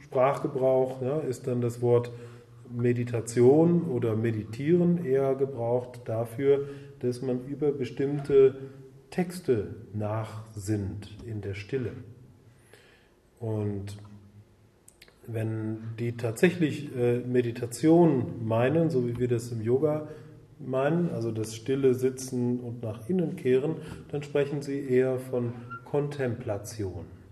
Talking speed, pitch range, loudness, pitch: 110 wpm, 115-140 Hz, -28 LUFS, 125 Hz